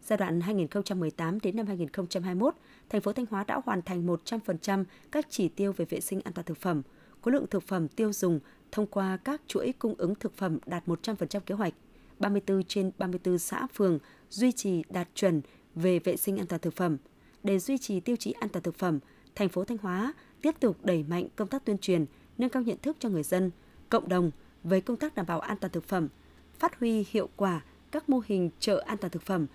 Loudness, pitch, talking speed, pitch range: -31 LUFS, 195 Hz, 220 wpm, 175-220 Hz